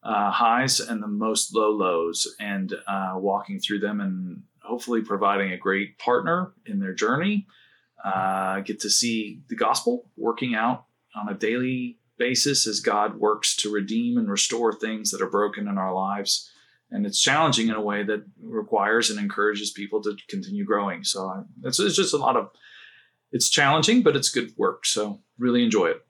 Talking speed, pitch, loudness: 180 wpm, 110 Hz, -24 LUFS